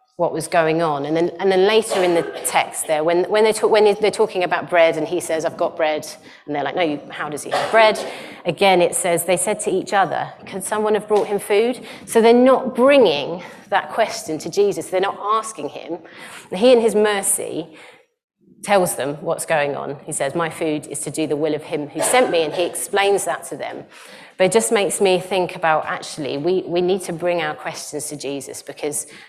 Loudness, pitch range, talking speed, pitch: -19 LUFS, 160-210 Hz, 230 wpm, 180 Hz